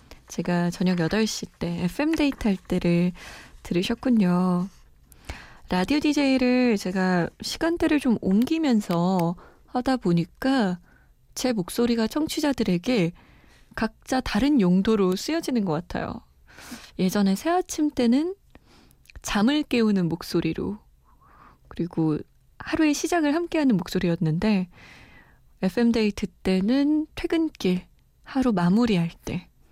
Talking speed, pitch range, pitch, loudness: 240 characters per minute, 180-265 Hz, 215 Hz, -24 LUFS